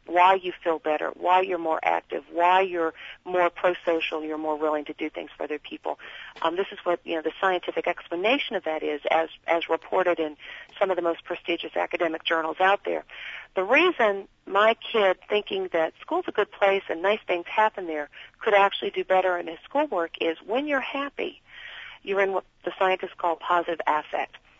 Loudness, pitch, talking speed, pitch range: -25 LUFS, 175 Hz, 195 wpm, 165-195 Hz